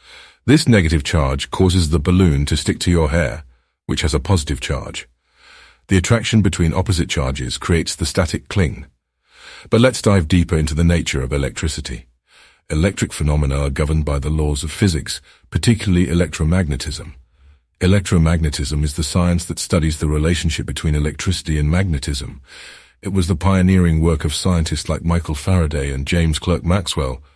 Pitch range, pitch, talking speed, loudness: 75-95 Hz, 85 Hz, 155 wpm, -18 LUFS